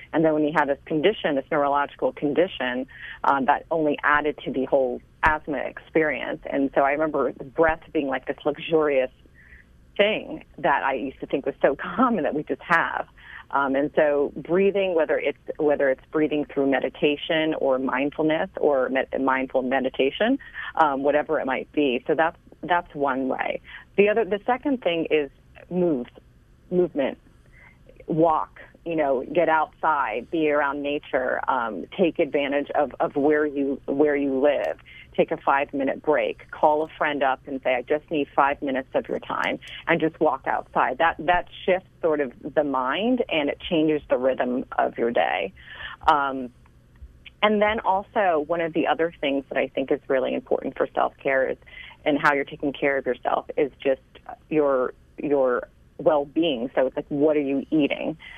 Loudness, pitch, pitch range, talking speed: -24 LUFS, 150 Hz, 140-165 Hz, 175 wpm